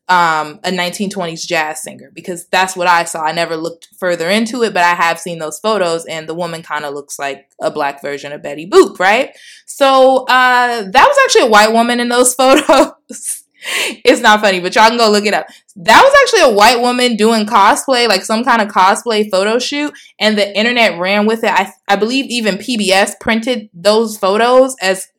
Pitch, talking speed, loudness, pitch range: 210 Hz, 205 wpm, -12 LUFS, 175-245 Hz